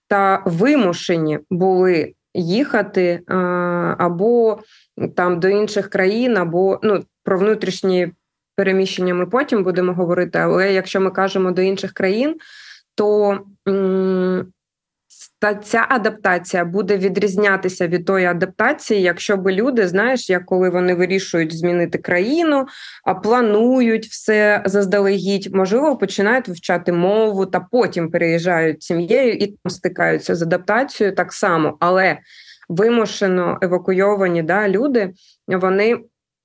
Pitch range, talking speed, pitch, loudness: 180-210 Hz, 120 wpm, 190 Hz, -17 LUFS